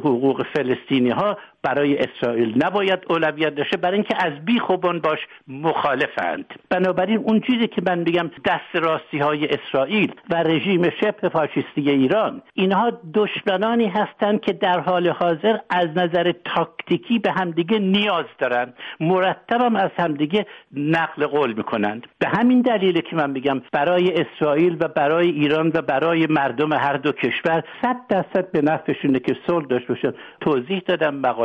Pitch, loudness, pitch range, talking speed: 170 Hz, -21 LUFS, 150-190 Hz, 145 wpm